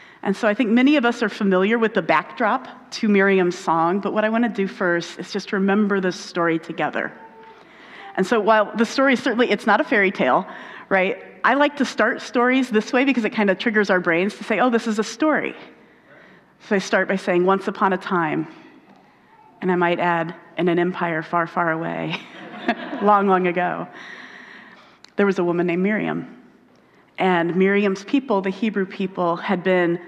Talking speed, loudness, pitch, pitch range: 195 wpm, -20 LUFS, 200 Hz, 180-225 Hz